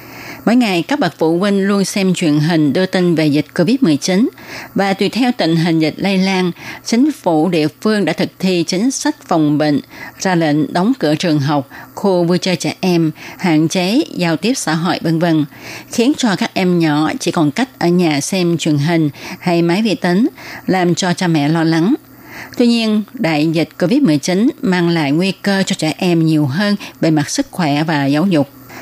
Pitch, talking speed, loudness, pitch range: 175 Hz, 200 wpm, -15 LUFS, 155-195 Hz